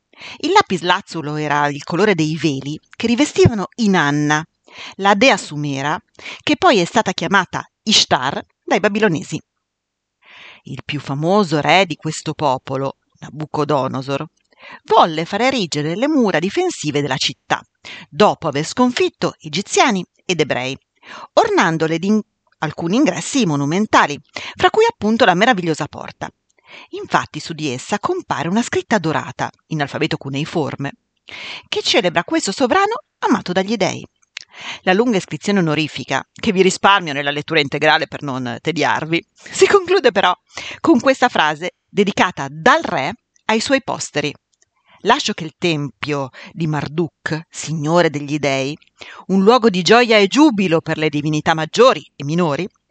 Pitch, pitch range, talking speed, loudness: 170 Hz, 150-220 Hz, 135 wpm, -17 LUFS